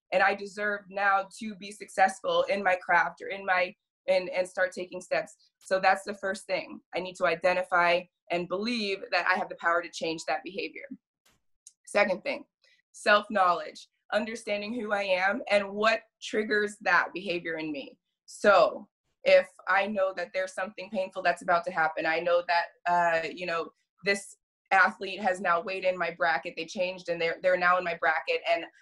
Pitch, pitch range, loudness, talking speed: 185 Hz, 175-205 Hz, -28 LUFS, 180 wpm